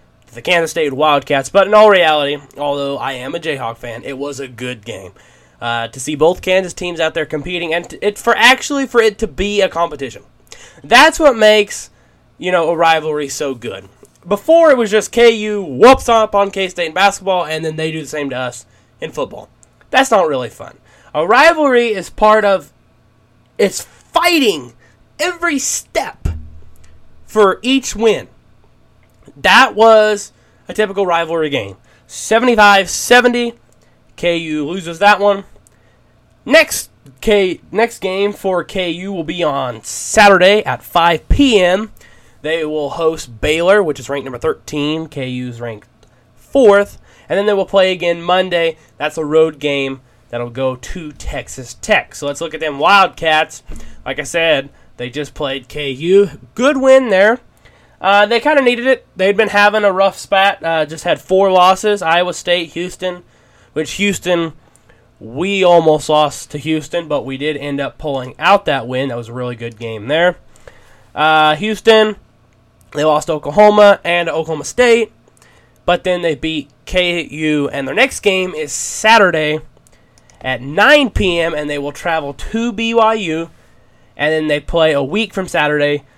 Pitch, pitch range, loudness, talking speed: 165 Hz, 145-200 Hz, -14 LUFS, 160 wpm